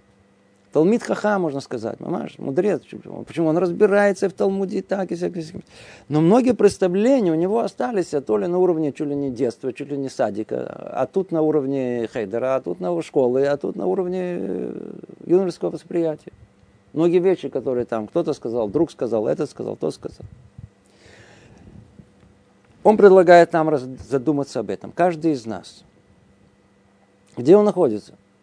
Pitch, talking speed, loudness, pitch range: 150 Hz, 155 wpm, -20 LUFS, 110-180 Hz